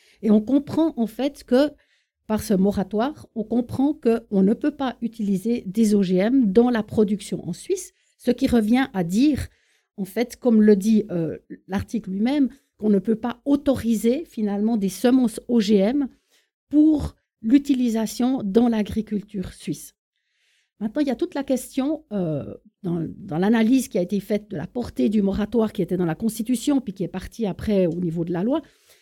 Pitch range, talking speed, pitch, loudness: 200-260 Hz, 180 wpm, 225 Hz, -22 LUFS